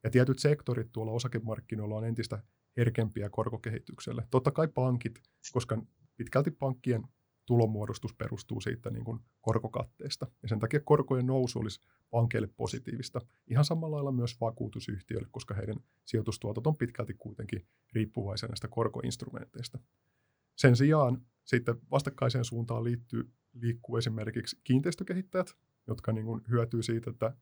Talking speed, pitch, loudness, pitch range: 125 wpm, 120 Hz, -33 LUFS, 115-130 Hz